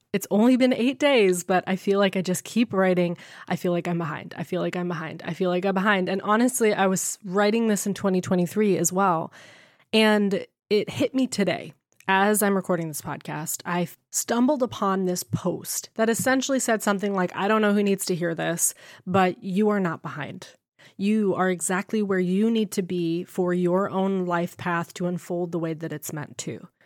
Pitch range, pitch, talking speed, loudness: 175-205 Hz, 190 Hz, 205 wpm, -24 LUFS